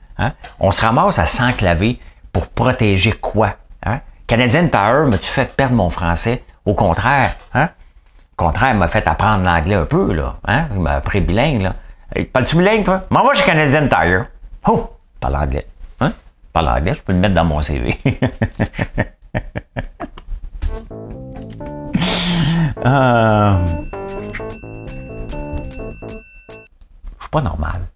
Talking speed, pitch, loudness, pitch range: 145 wpm, 100 Hz, -16 LUFS, 80-120 Hz